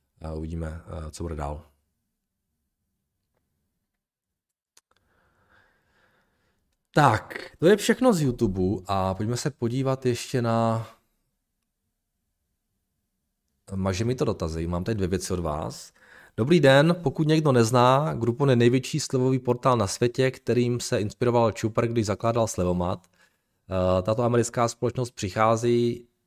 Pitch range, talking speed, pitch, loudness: 95-125 Hz, 110 wpm, 115 Hz, -24 LUFS